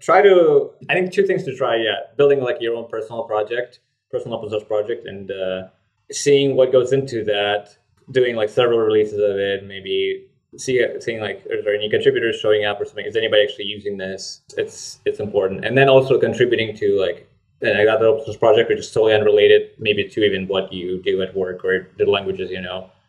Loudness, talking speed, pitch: -19 LUFS, 210 wpm, 150 Hz